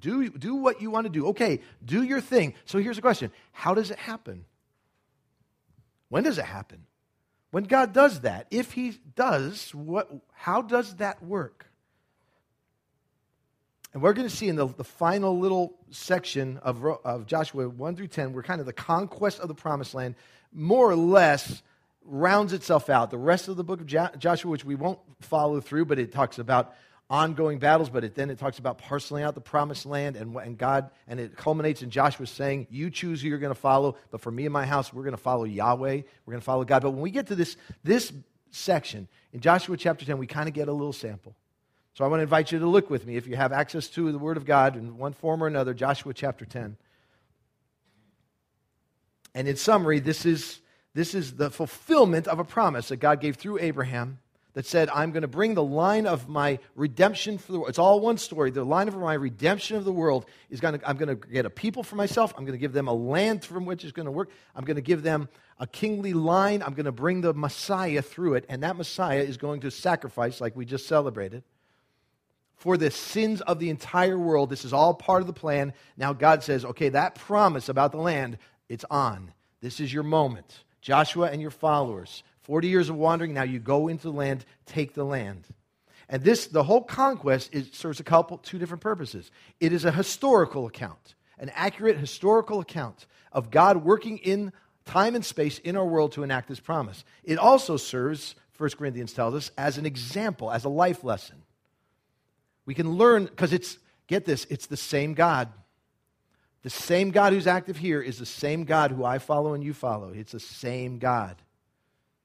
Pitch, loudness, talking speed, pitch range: 150 Hz, -26 LUFS, 210 wpm, 135-180 Hz